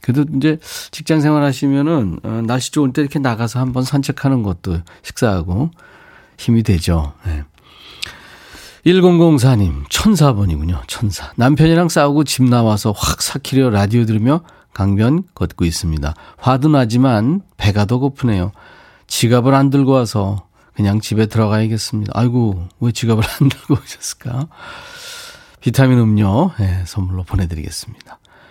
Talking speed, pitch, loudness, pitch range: 300 characters per minute, 120 Hz, -16 LUFS, 100-140 Hz